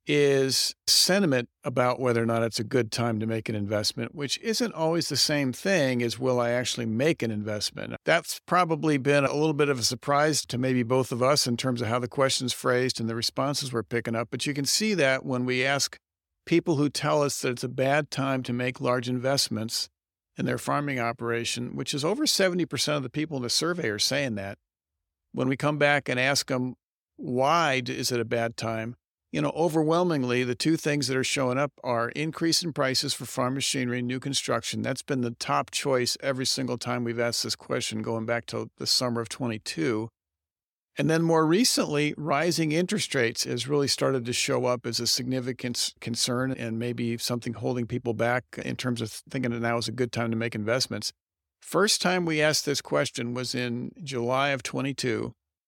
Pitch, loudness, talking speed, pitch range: 125 Hz, -26 LUFS, 205 wpm, 115-145 Hz